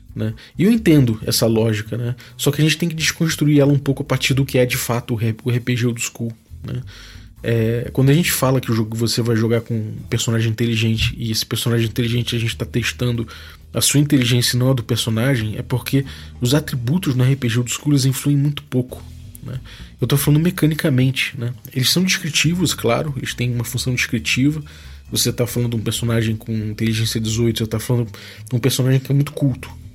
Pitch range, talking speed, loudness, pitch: 115-135 Hz, 215 wpm, -19 LUFS, 120 Hz